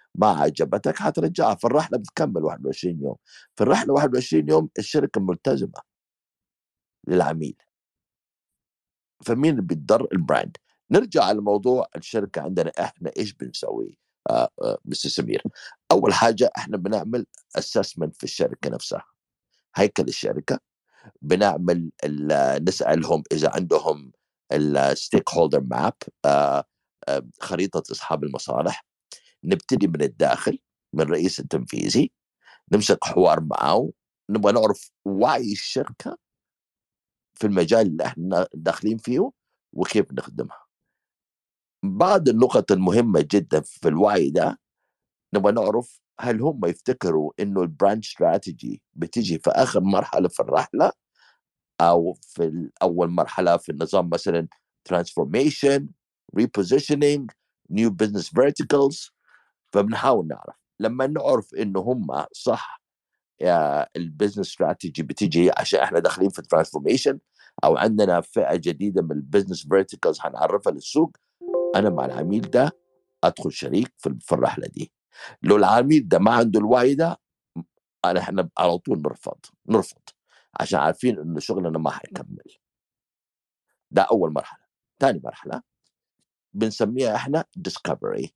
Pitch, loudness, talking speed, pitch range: 100 Hz, -22 LUFS, 110 wpm, 80-125 Hz